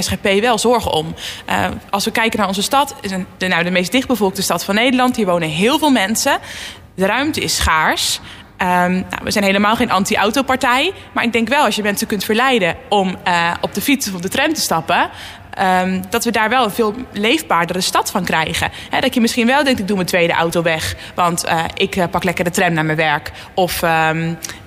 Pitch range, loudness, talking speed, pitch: 180-235 Hz, -16 LUFS, 220 wpm, 200 Hz